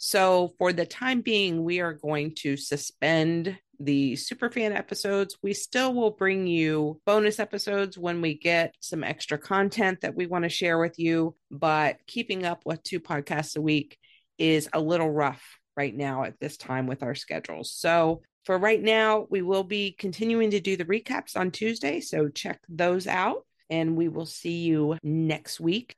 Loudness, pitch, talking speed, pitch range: -27 LUFS, 170 Hz, 180 wpm, 155-200 Hz